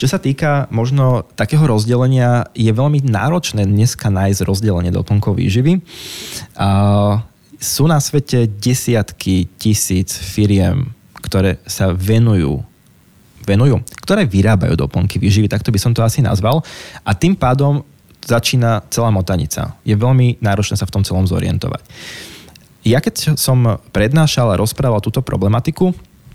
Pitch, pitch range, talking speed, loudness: 110 Hz, 100-130 Hz, 130 wpm, -15 LUFS